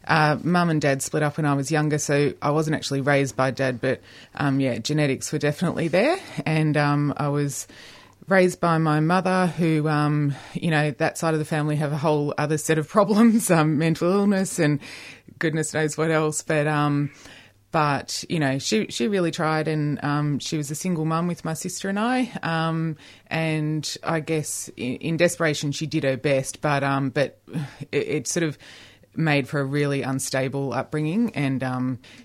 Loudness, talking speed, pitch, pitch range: -23 LUFS, 190 wpm, 150 Hz, 140-160 Hz